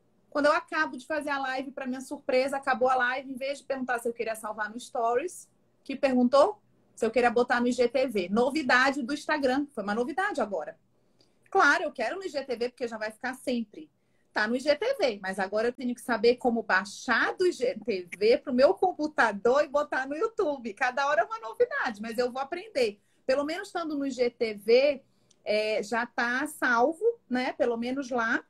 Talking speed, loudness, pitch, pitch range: 190 wpm, -28 LUFS, 260 Hz, 240-300 Hz